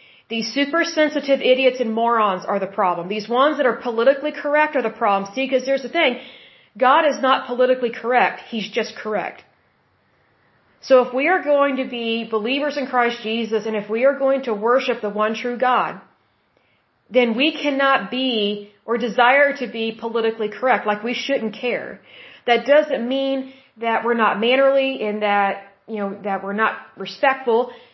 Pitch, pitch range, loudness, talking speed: 245 Hz, 220-270 Hz, -19 LUFS, 175 wpm